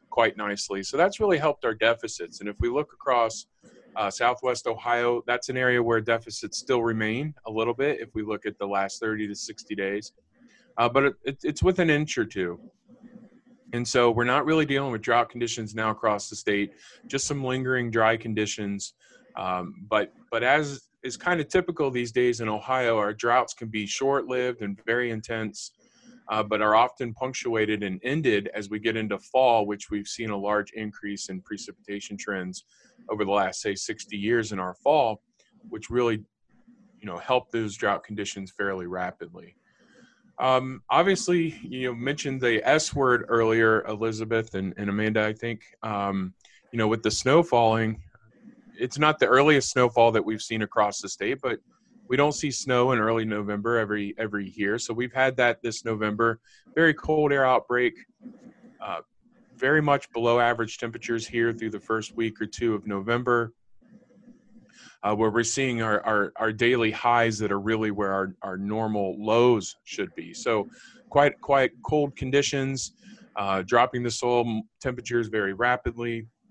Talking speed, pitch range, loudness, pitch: 175 wpm, 105-130 Hz, -26 LUFS, 115 Hz